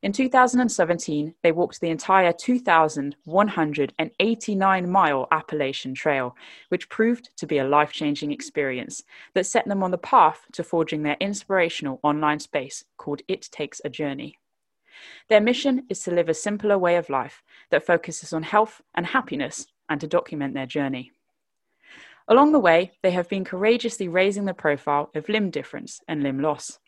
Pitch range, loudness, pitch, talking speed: 150-200 Hz, -23 LUFS, 170 Hz, 160 wpm